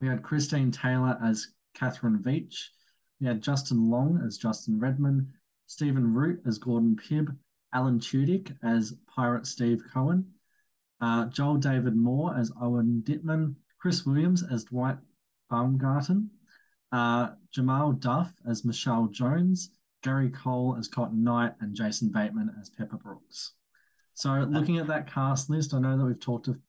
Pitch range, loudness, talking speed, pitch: 120-155 Hz, -29 LUFS, 150 wpm, 130 Hz